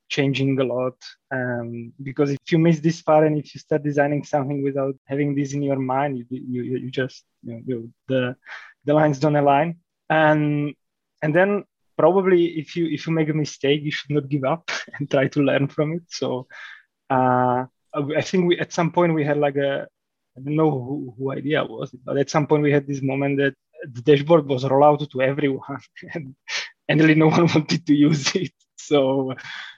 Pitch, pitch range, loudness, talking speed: 145 Hz, 135-155 Hz, -21 LUFS, 205 wpm